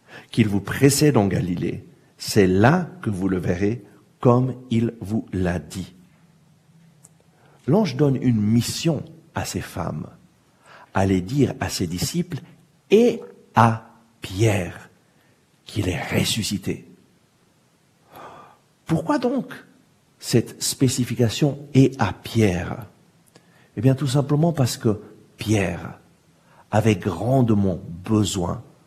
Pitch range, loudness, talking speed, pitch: 105-150 Hz, -22 LUFS, 110 wpm, 120 Hz